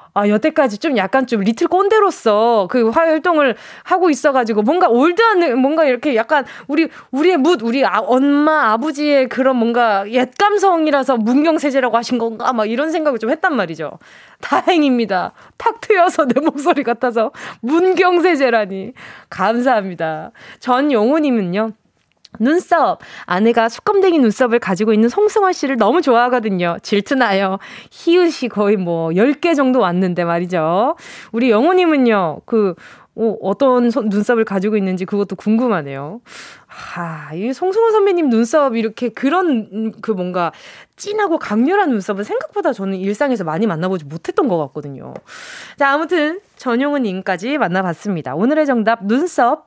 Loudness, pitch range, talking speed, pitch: -16 LUFS, 210-310 Hz, 325 characters per minute, 245 Hz